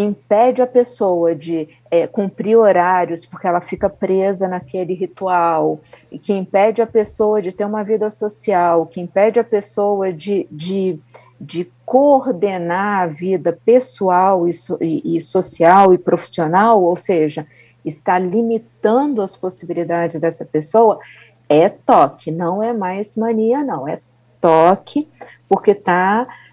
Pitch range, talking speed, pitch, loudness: 170-215 Hz, 135 wpm, 190 Hz, -16 LUFS